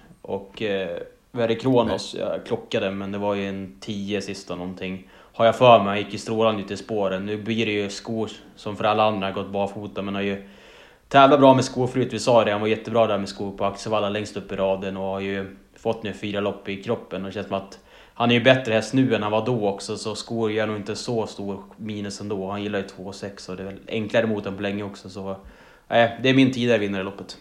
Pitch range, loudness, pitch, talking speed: 100-115 Hz, -23 LUFS, 105 Hz, 260 wpm